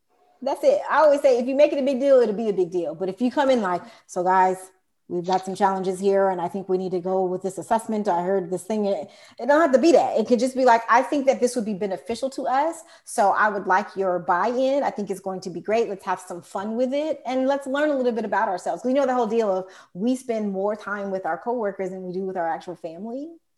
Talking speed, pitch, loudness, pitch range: 290 wpm, 215 Hz, -23 LUFS, 185-260 Hz